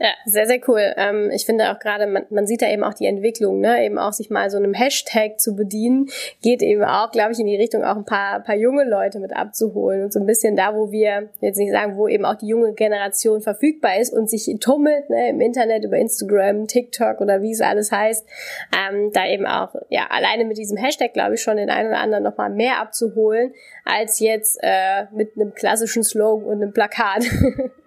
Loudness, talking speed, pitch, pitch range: -19 LUFS, 225 wpm, 215 Hz, 210-230 Hz